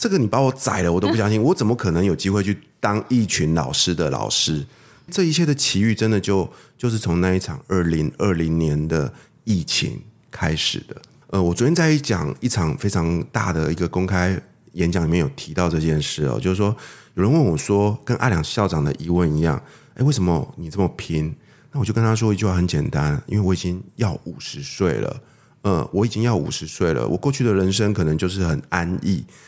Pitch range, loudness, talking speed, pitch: 85-115 Hz, -21 LUFS, 315 characters per minute, 95 Hz